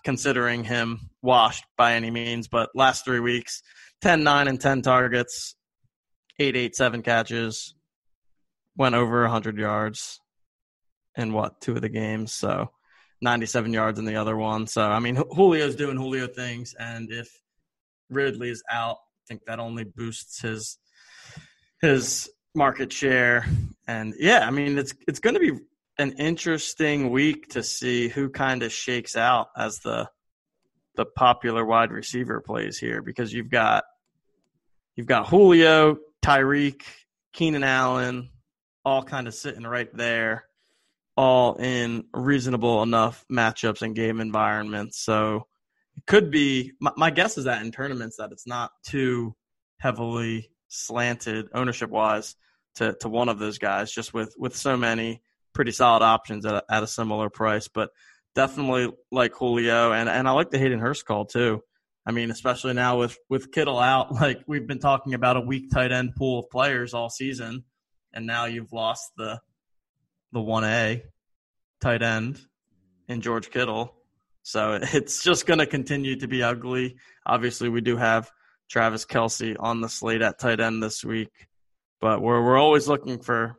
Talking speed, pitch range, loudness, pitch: 160 wpm, 115-135 Hz, -24 LUFS, 120 Hz